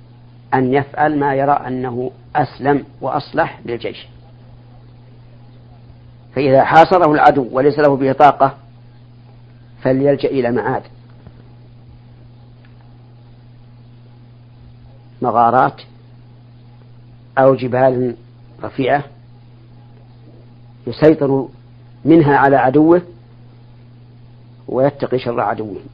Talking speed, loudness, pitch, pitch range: 65 wpm, -15 LUFS, 120 Hz, 120-130 Hz